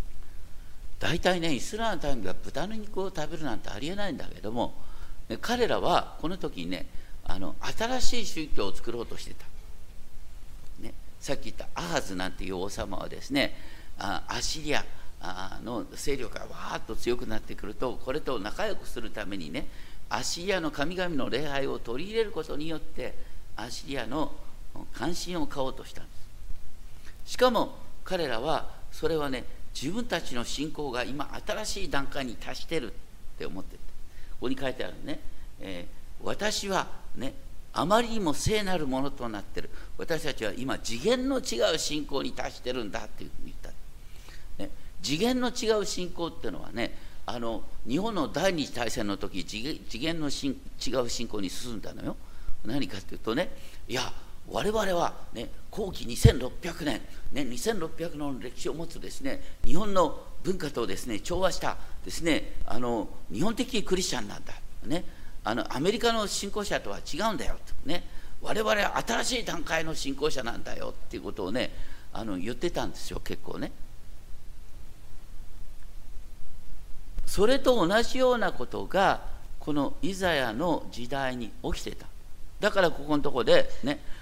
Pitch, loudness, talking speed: 155 Hz, -31 LUFS, 305 characters per minute